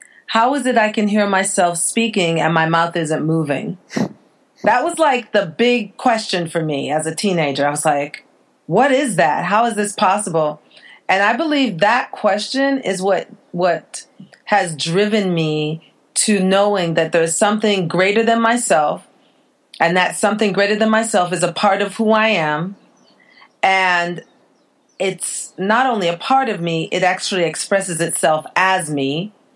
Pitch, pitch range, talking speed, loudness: 195 Hz, 165-220 Hz, 160 wpm, -17 LUFS